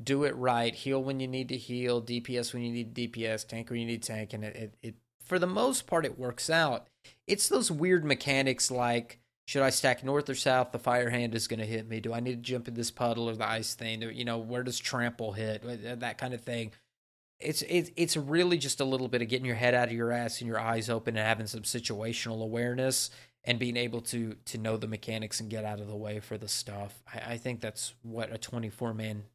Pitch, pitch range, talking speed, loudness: 120 Hz, 115-130 Hz, 245 wpm, -32 LUFS